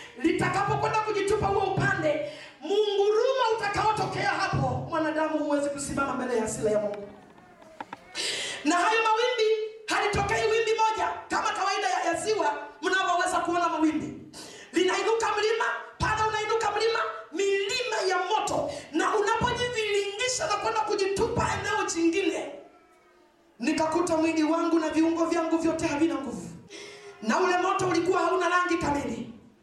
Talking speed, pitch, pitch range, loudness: 105 wpm, 360 Hz, 315-425 Hz, -26 LUFS